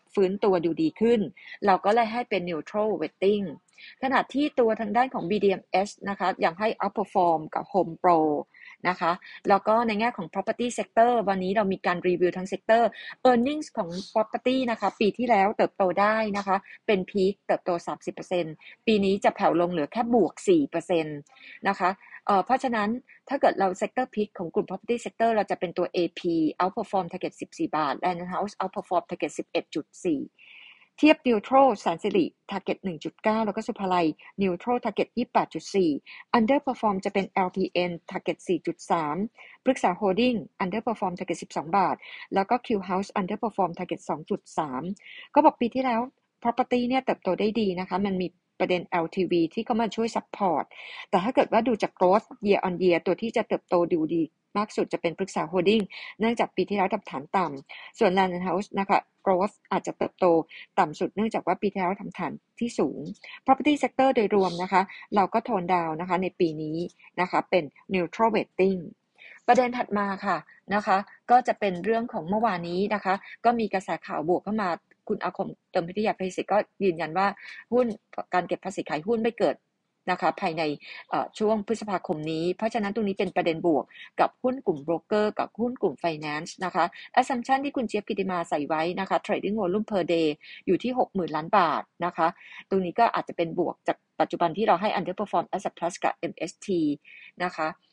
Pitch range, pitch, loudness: 180-225 Hz, 195 Hz, -26 LUFS